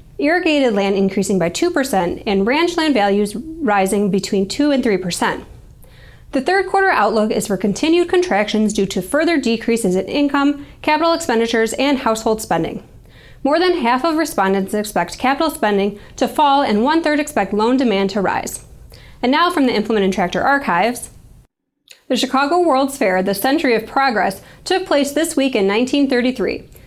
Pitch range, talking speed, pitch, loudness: 205-295 Hz, 160 wpm, 245 Hz, -17 LUFS